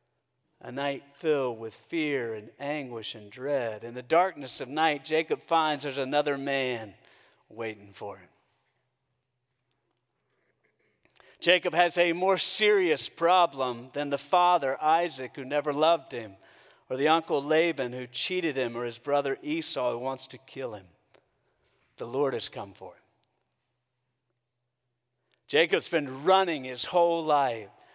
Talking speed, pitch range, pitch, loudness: 135 wpm, 125-160 Hz, 135 Hz, -27 LUFS